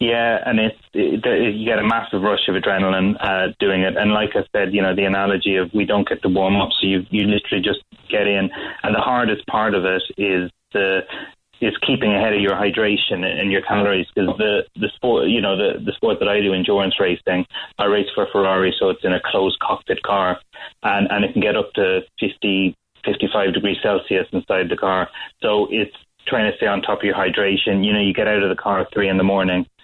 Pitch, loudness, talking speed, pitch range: 100 Hz, -19 LUFS, 235 wpm, 95-105 Hz